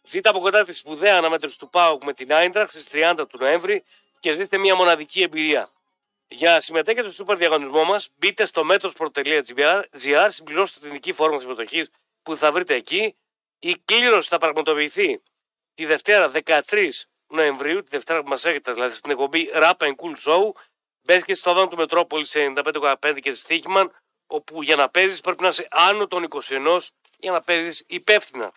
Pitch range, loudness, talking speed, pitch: 155-195 Hz, -19 LUFS, 175 wpm, 170 Hz